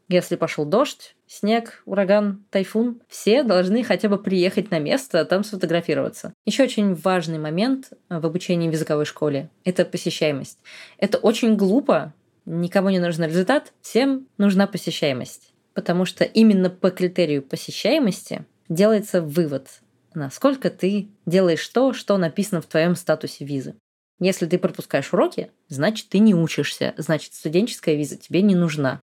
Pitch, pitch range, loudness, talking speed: 185 Hz, 165-210 Hz, -21 LUFS, 140 wpm